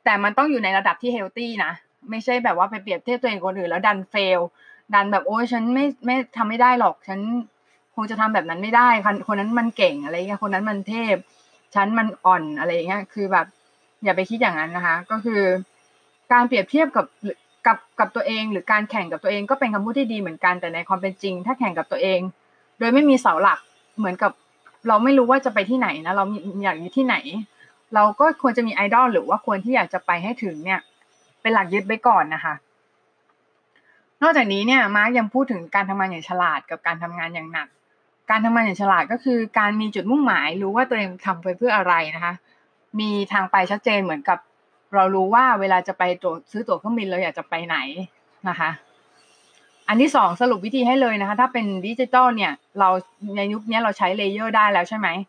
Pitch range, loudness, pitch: 190-240 Hz, -21 LUFS, 210 Hz